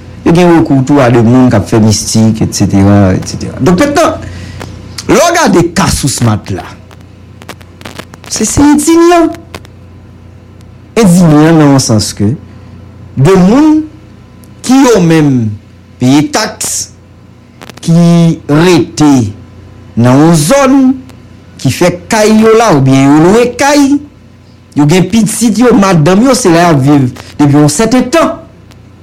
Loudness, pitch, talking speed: -7 LUFS, 135 Hz, 140 wpm